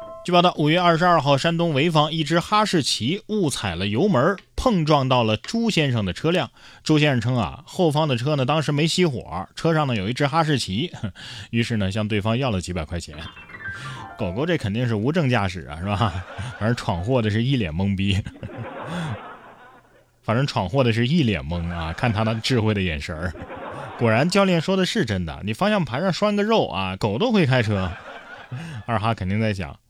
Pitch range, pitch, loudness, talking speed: 100-160 Hz, 125 Hz, -22 LUFS, 280 characters per minute